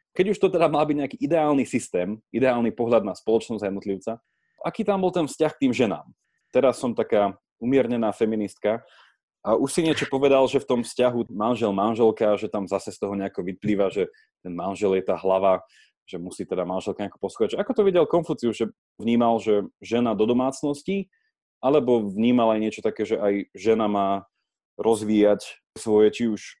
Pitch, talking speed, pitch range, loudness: 115 Hz, 185 wpm, 105-150 Hz, -24 LUFS